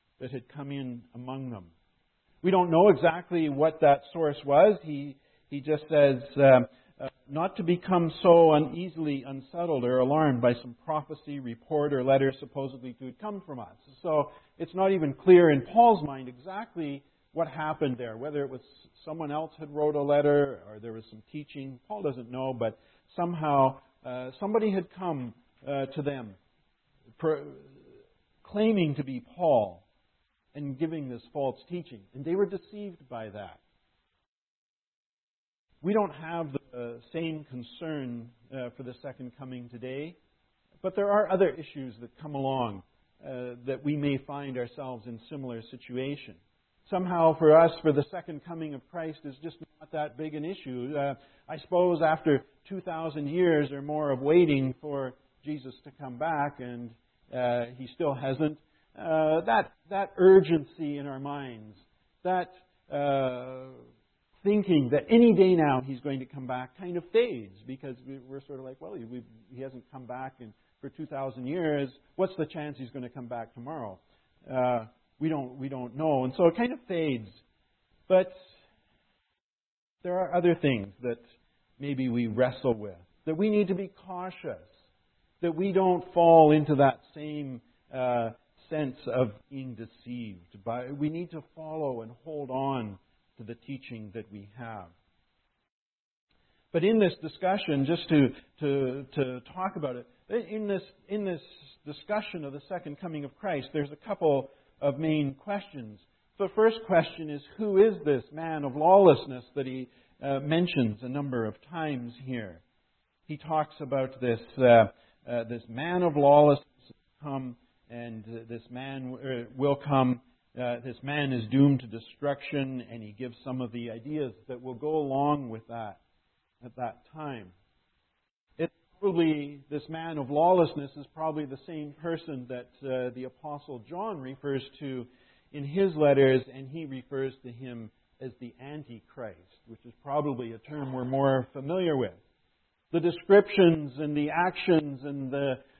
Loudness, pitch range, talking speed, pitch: -28 LUFS, 125-160 Hz, 165 wpm, 140 Hz